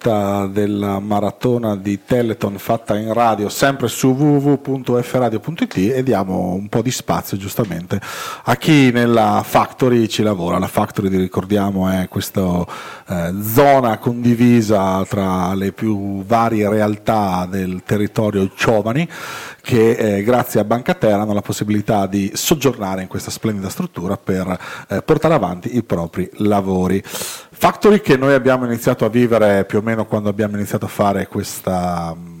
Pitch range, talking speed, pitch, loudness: 100-120 Hz, 145 wpm, 105 Hz, -17 LUFS